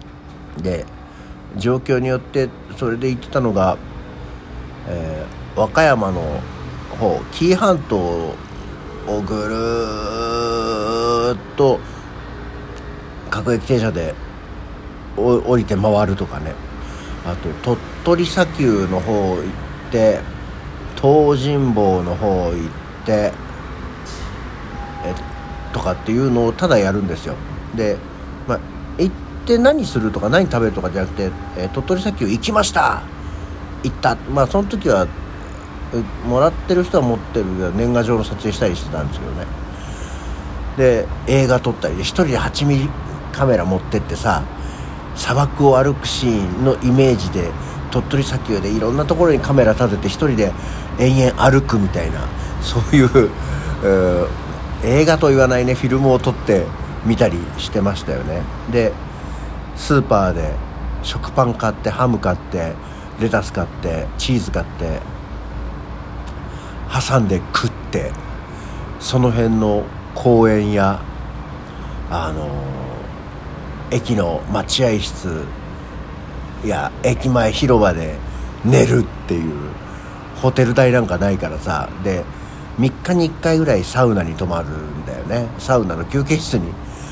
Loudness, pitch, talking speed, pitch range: -18 LUFS, 100 Hz, 240 characters per minute, 75-120 Hz